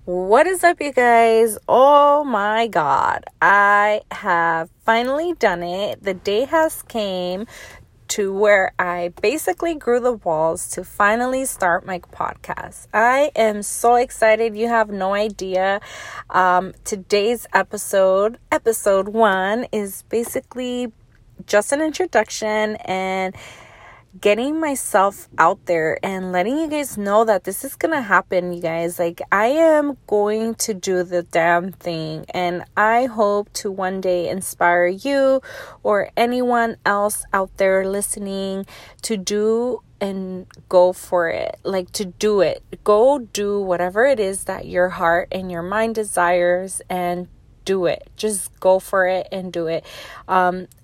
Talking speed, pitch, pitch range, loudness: 145 wpm, 200 Hz, 180-225 Hz, -19 LUFS